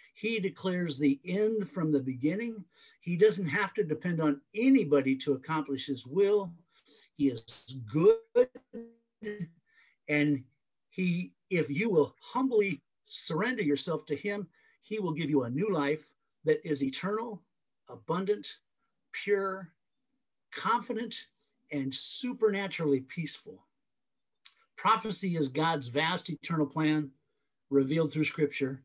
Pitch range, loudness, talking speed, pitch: 145-215 Hz, -31 LUFS, 115 wpm, 165 Hz